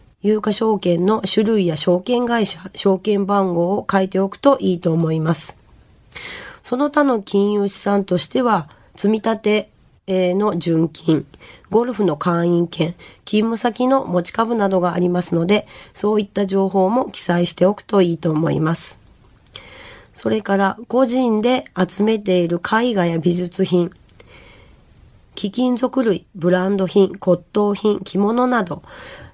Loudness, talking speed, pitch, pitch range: -18 LUFS, 260 characters per minute, 195 Hz, 180-215 Hz